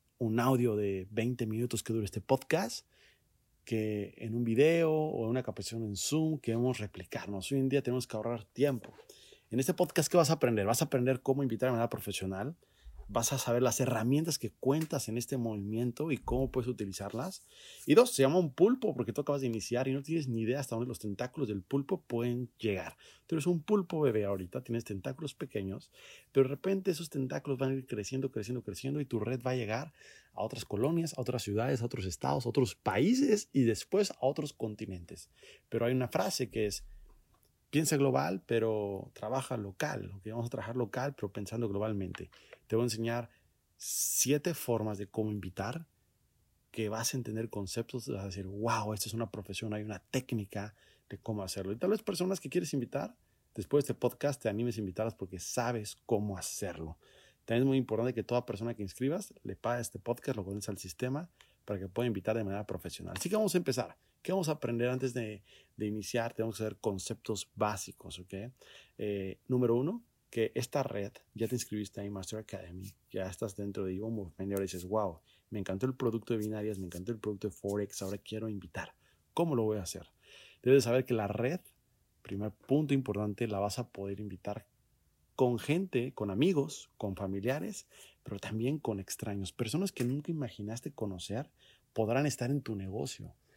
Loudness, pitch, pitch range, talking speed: -34 LUFS, 115 Hz, 105-130 Hz, 195 wpm